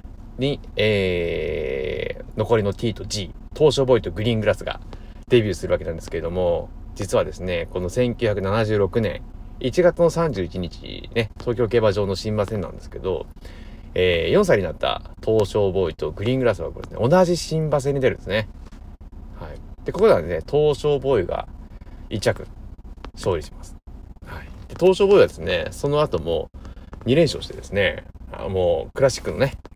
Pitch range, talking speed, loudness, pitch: 95-150 Hz, 310 characters per minute, -22 LUFS, 115 Hz